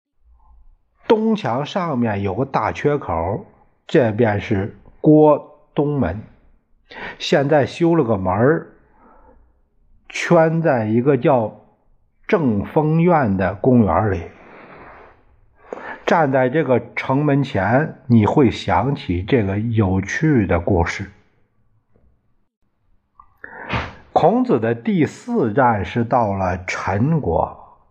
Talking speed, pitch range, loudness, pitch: 135 characters per minute, 100-150 Hz, -18 LUFS, 120 Hz